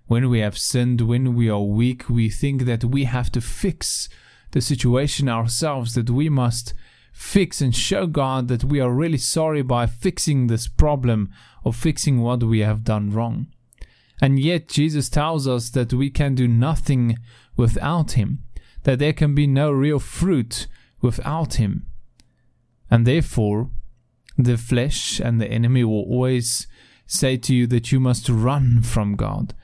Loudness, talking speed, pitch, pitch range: -21 LUFS, 160 wpm, 125 Hz, 115-140 Hz